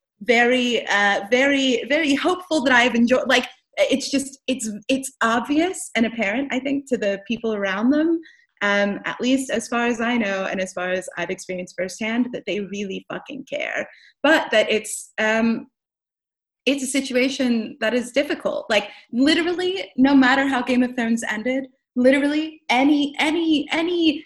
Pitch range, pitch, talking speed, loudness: 220-285 Hz, 255 Hz, 165 wpm, -21 LUFS